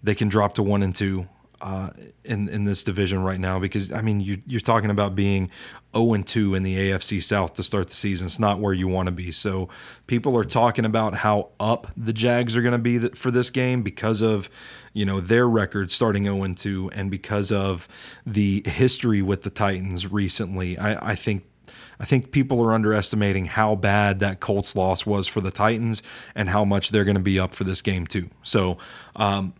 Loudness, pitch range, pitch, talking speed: -23 LUFS, 95-110 Hz, 100 Hz, 215 wpm